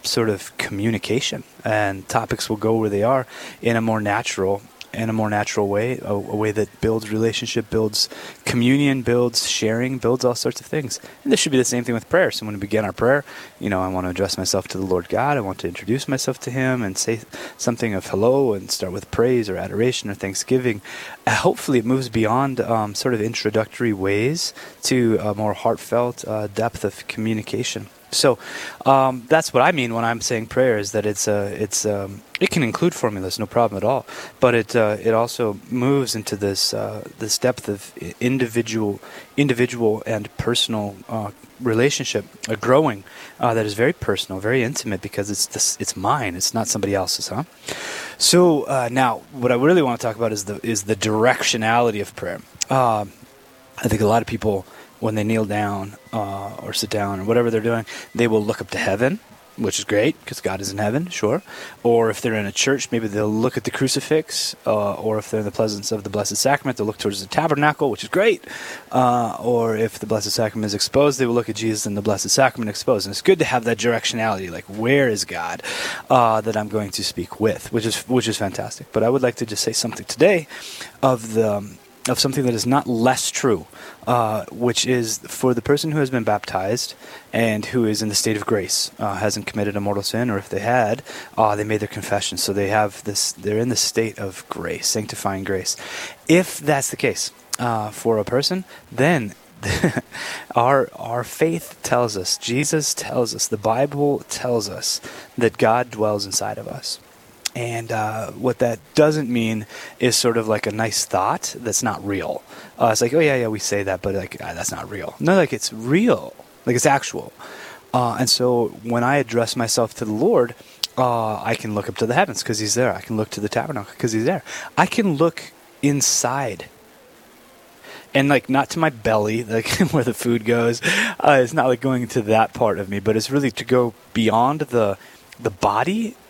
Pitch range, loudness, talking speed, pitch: 105-125 Hz, -21 LUFS, 210 wpm, 115 Hz